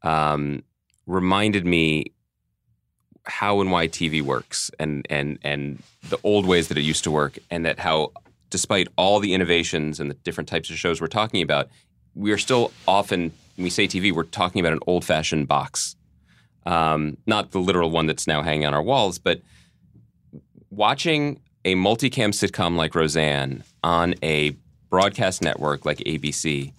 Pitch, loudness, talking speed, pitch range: 80 Hz, -22 LUFS, 165 wpm, 75-95 Hz